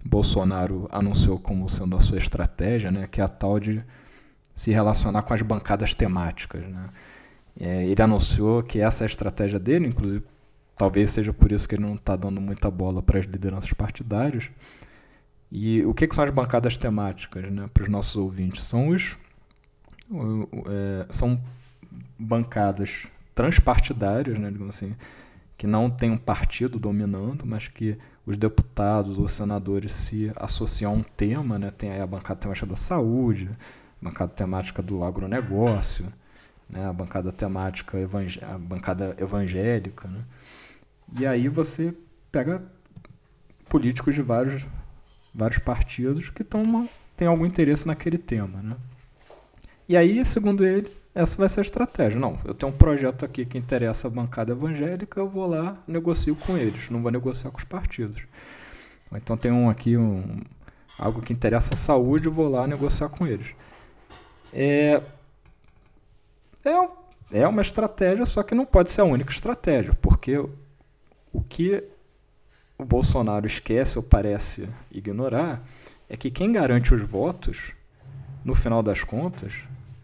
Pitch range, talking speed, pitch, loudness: 100-135 Hz, 150 wpm, 115 Hz, -25 LUFS